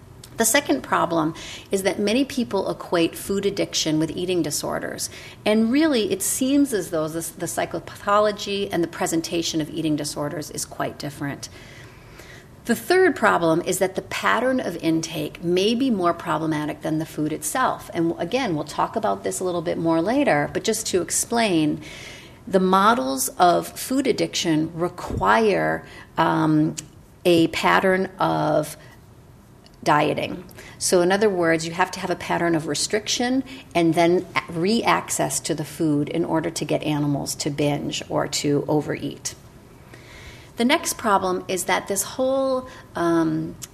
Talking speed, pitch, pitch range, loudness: 150 wpm, 170 Hz, 155-200 Hz, -22 LUFS